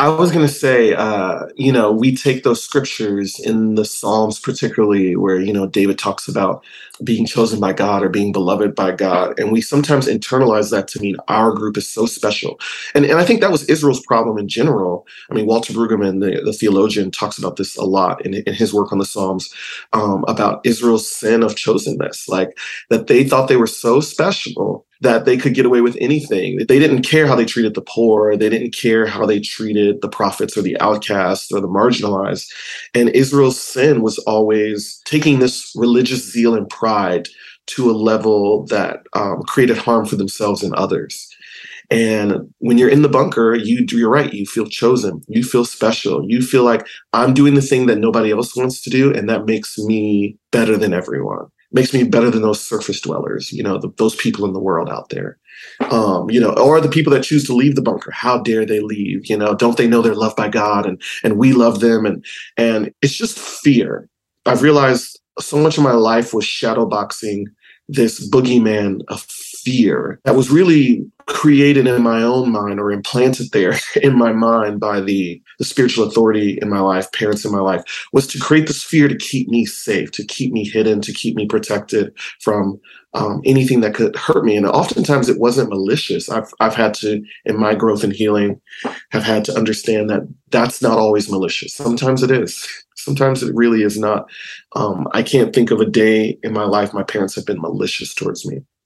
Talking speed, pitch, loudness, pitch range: 205 wpm, 115 Hz, -16 LUFS, 105-130 Hz